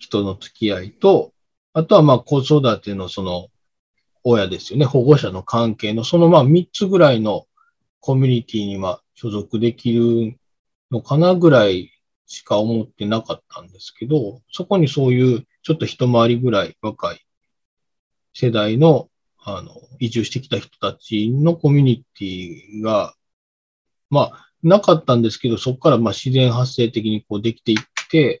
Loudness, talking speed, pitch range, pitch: -17 LUFS, 305 characters per minute, 110-145 Hz, 120 Hz